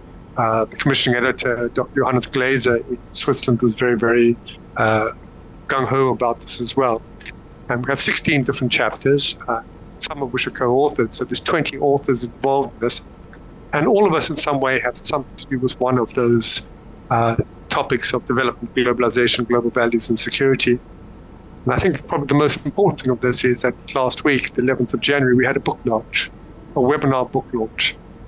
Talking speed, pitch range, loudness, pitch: 185 wpm, 115-135 Hz, -19 LUFS, 125 Hz